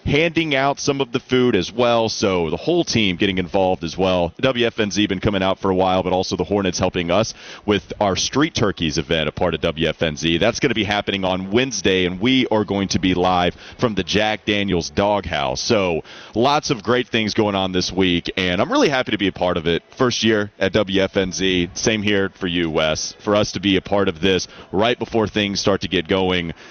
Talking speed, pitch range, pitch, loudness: 220 wpm, 90-110 Hz, 100 Hz, -19 LUFS